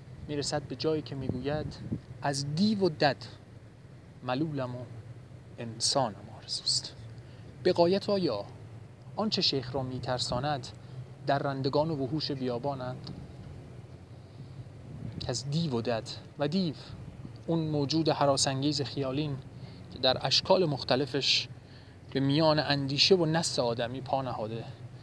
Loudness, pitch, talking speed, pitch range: -30 LUFS, 135 Hz, 115 wpm, 125-145 Hz